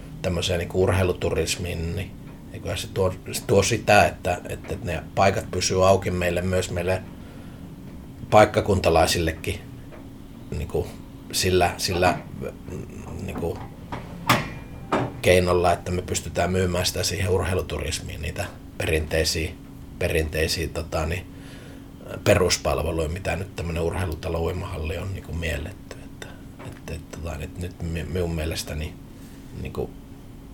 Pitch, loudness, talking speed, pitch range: 90 Hz, -24 LUFS, 105 wpm, 85-95 Hz